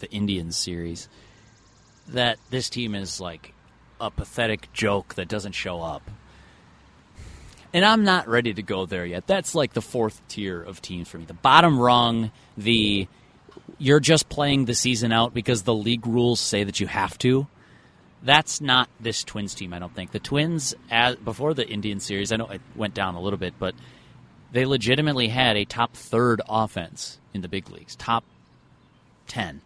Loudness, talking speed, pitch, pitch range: -23 LUFS, 175 wpm, 115 Hz, 100-125 Hz